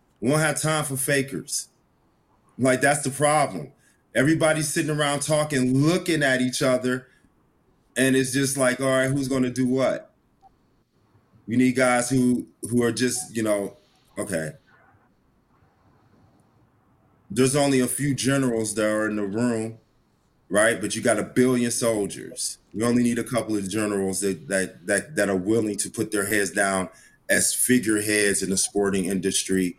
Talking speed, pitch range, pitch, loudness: 160 wpm, 105-135 Hz, 125 Hz, -23 LUFS